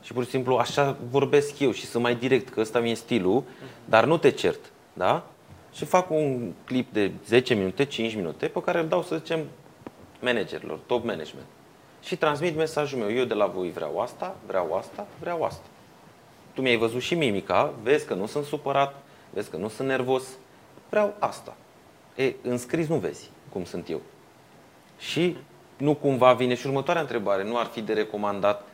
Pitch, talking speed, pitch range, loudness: 130 Hz, 185 wpm, 120-150 Hz, -26 LUFS